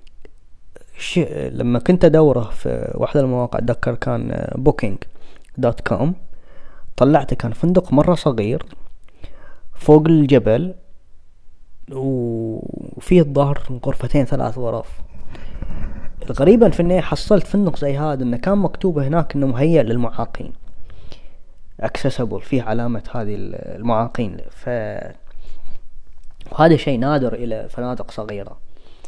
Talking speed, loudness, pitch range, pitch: 105 wpm, -18 LUFS, 115-155 Hz, 130 Hz